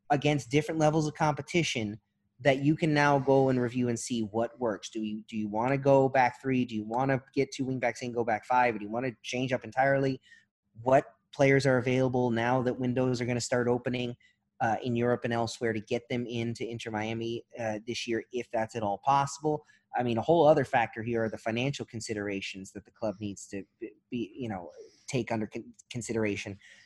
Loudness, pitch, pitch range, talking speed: -29 LUFS, 120 Hz, 115-135 Hz, 220 wpm